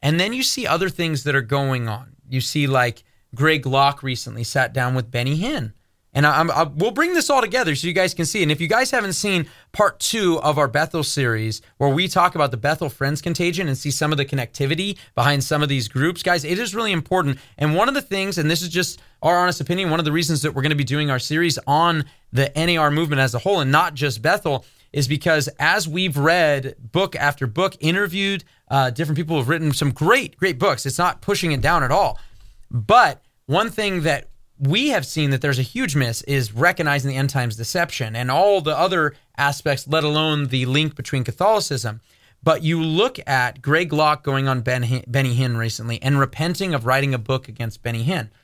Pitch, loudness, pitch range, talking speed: 145 Hz, -20 LUFS, 130-170 Hz, 225 wpm